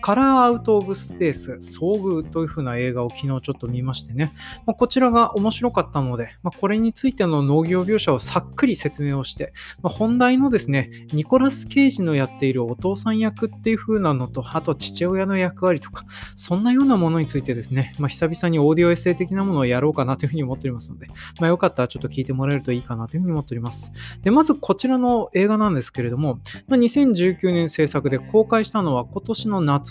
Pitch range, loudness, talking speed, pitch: 135-215 Hz, -21 LUFS, 470 characters per minute, 165 Hz